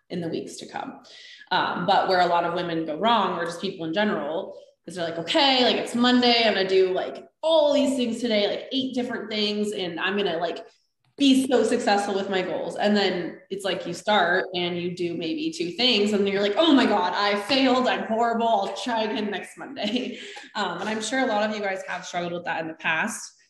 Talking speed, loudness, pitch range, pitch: 235 wpm, -24 LUFS, 180-235 Hz, 205 Hz